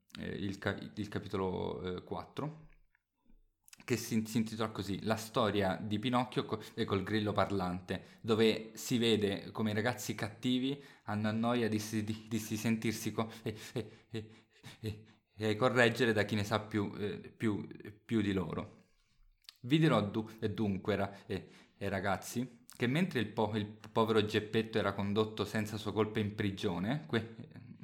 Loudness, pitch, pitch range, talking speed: -35 LUFS, 110 Hz, 105-115 Hz, 160 wpm